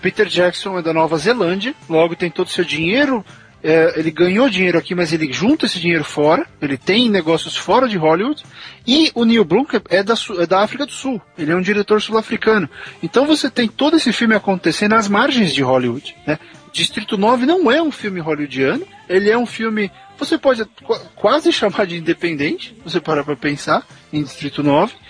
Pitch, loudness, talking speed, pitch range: 190 Hz, -16 LUFS, 195 wpm, 165-235 Hz